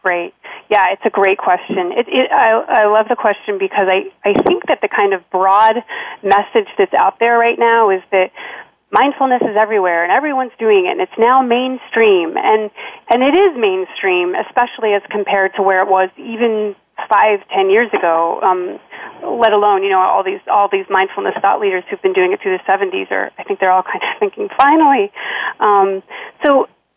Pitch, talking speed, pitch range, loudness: 215 Hz, 195 wpm, 195-280 Hz, -14 LUFS